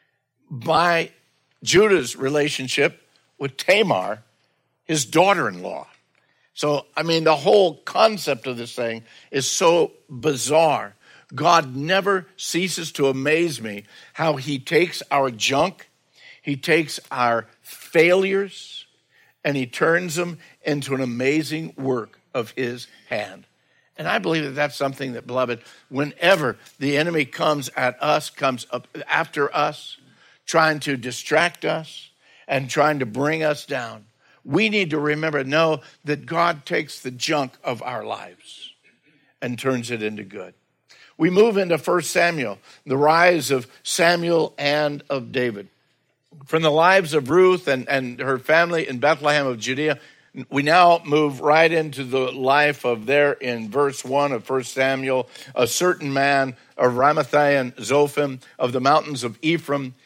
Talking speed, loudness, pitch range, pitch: 145 wpm, -21 LUFS, 130-160 Hz, 145 Hz